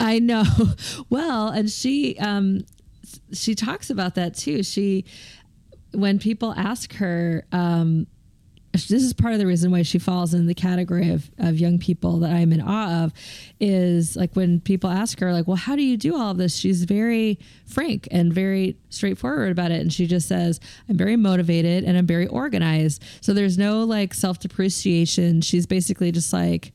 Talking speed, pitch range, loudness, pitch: 185 wpm, 170-205 Hz, -22 LUFS, 185 Hz